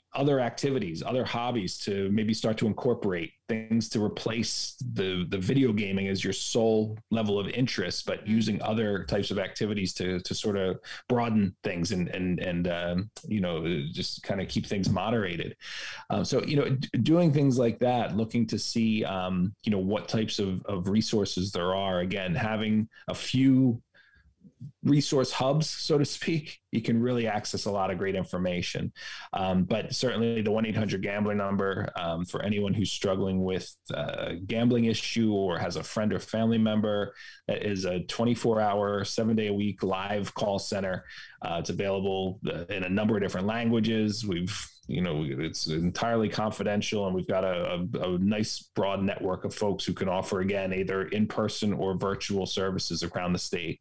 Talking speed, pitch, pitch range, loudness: 175 wpm, 105 Hz, 95-115 Hz, -29 LUFS